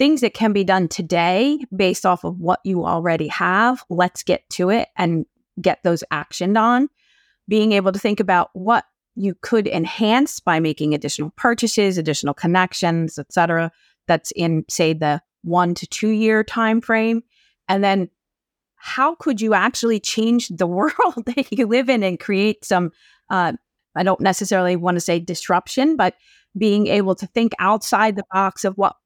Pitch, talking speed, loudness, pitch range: 195 Hz, 170 wpm, -19 LUFS, 175-225 Hz